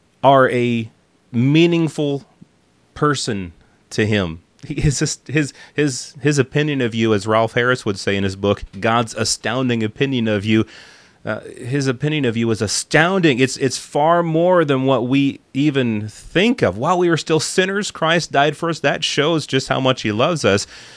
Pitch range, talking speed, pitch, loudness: 110-150 Hz, 175 wpm, 130 Hz, -18 LUFS